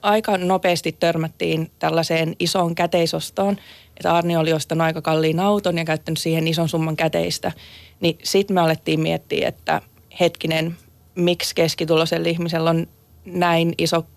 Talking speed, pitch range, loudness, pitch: 135 wpm, 160-175 Hz, -21 LUFS, 165 Hz